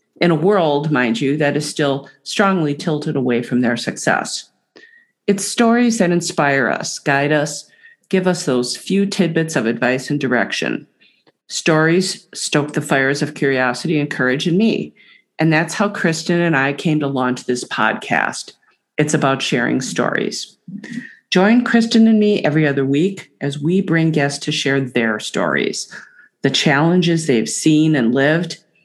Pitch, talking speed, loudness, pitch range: 155 Hz, 160 wpm, -17 LUFS, 140-190 Hz